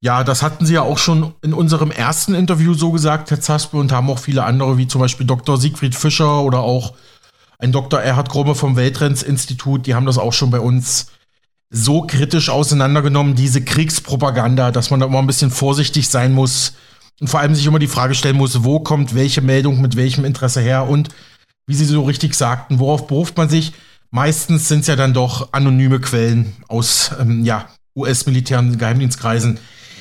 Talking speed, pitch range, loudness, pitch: 190 wpm, 125-150 Hz, -15 LUFS, 135 Hz